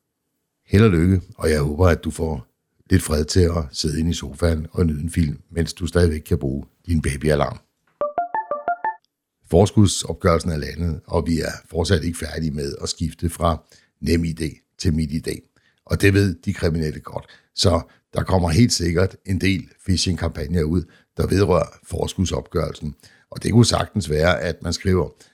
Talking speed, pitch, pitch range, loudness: 170 wpm, 85 Hz, 80-95 Hz, -21 LUFS